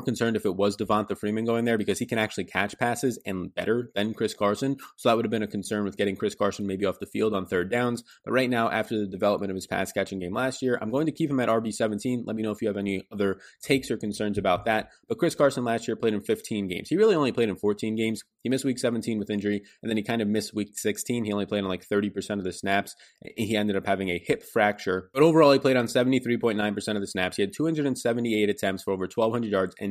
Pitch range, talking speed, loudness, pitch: 100-120 Hz, 275 wpm, -27 LUFS, 110 Hz